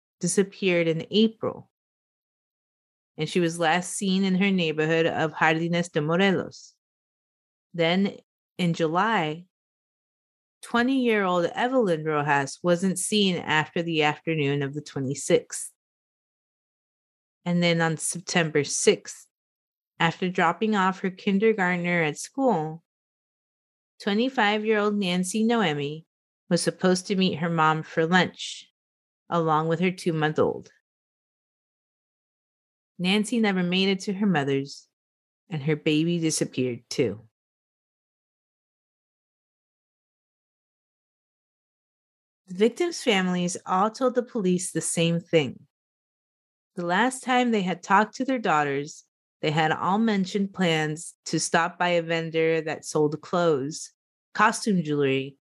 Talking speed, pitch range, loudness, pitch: 115 wpm, 155-195 Hz, -25 LUFS, 175 Hz